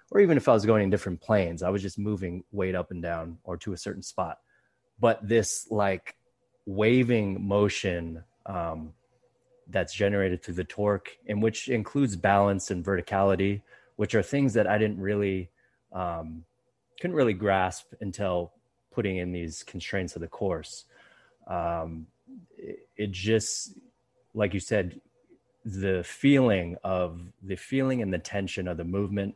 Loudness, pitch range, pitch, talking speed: -28 LUFS, 90-110 Hz, 100 Hz, 155 wpm